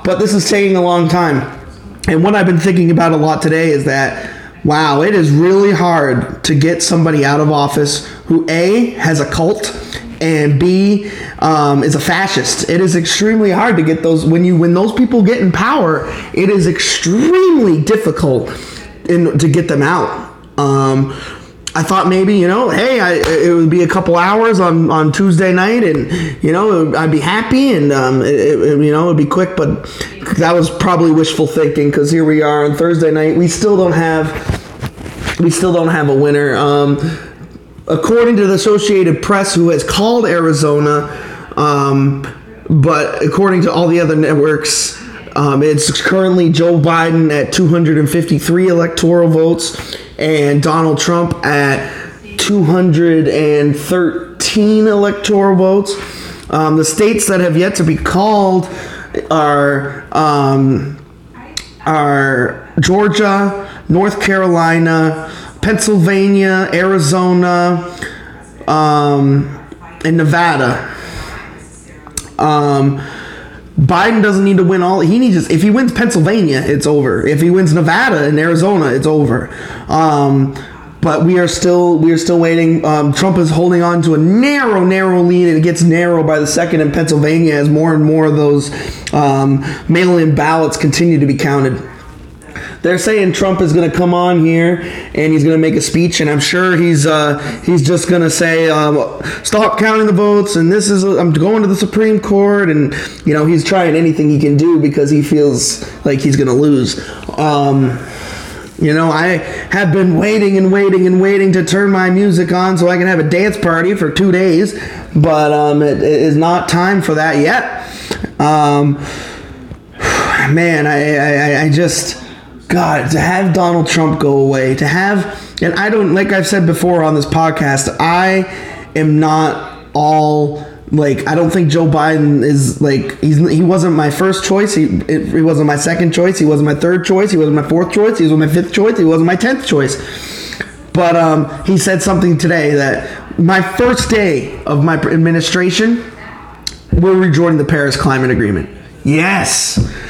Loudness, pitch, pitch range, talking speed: -11 LUFS, 165 Hz, 150-185 Hz, 165 wpm